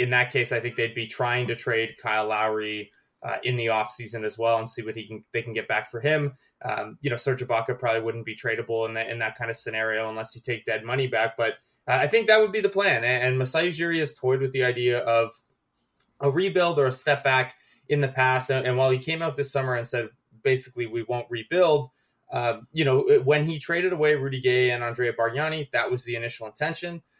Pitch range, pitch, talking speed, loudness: 115-140 Hz, 125 Hz, 245 wpm, -25 LUFS